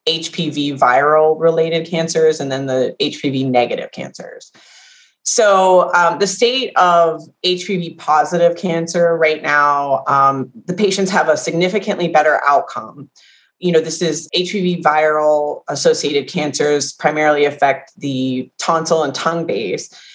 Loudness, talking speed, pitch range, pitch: -15 LUFS, 130 wpm, 150-180 Hz, 165 Hz